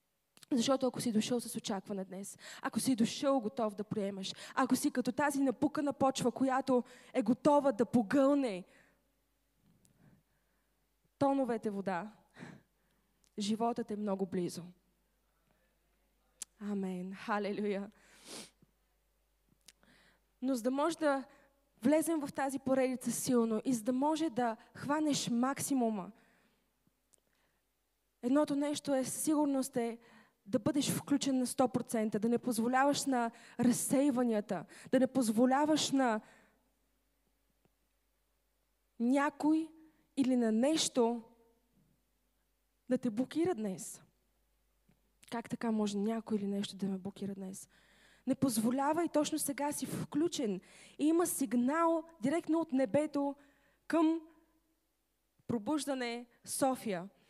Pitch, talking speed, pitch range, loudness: 250 Hz, 105 wpm, 215-280 Hz, -34 LUFS